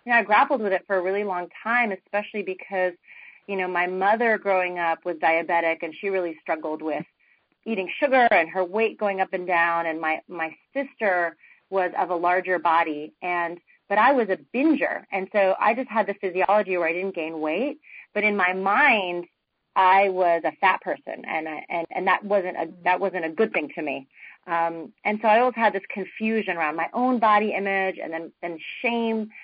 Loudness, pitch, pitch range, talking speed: -24 LUFS, 190 Hz, 170-210 Hz, 210 wpm